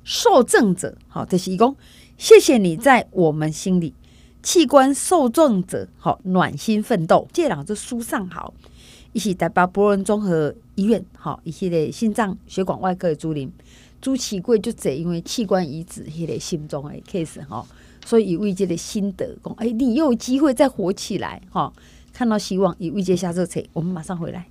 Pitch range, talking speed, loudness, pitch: 170-230 Hz, 280 characters per minute, -20 LUFS, 195 Hz